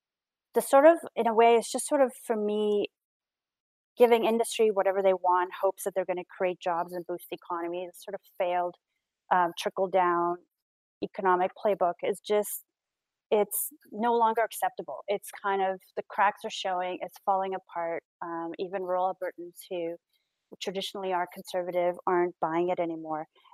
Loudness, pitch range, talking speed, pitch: -28 LUFS, 180-210 Hz, 165 wpm, 190 Hz